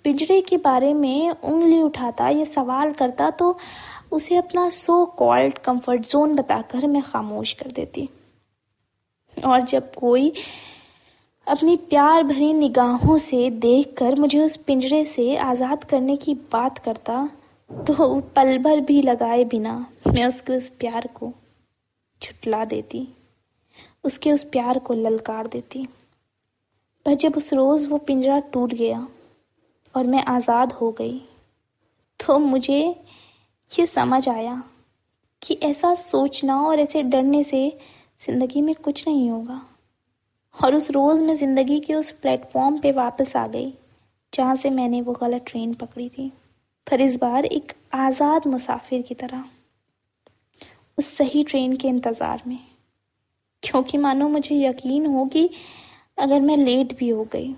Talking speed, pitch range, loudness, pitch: 140 wpm, 245-295 Hz, -21 LUFS, 270 Hz